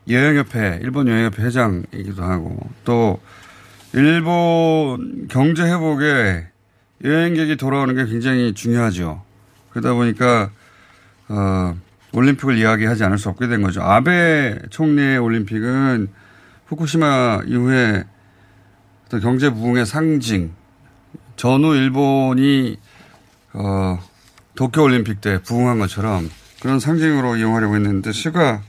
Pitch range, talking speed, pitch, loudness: 100-135 Hz, 255 characters per minute, 115 Hz, -17 LUFS